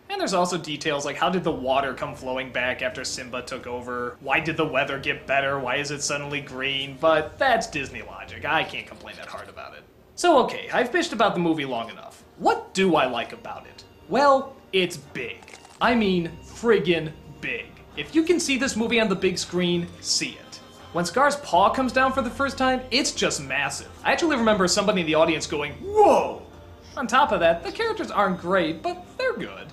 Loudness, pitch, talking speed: -23 LUFS, 180 Hz, 210 wpm